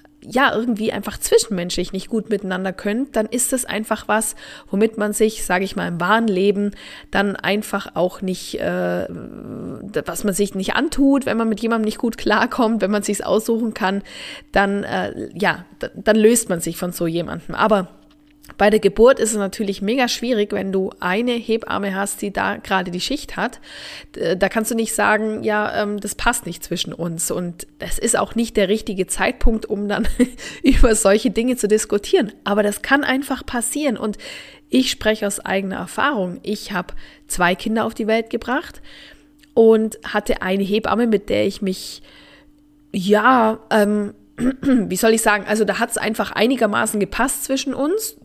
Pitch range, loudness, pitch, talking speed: 195-235 Hz, -19 LUFS, 215 Hz, 180 wpm